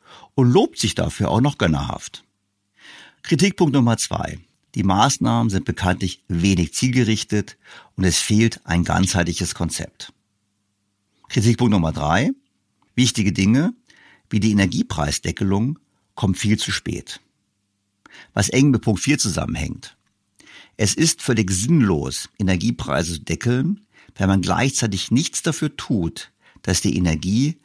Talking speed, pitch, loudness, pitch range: 120 wpm, 105 Hz, -20 LUFS, 95-125 Hz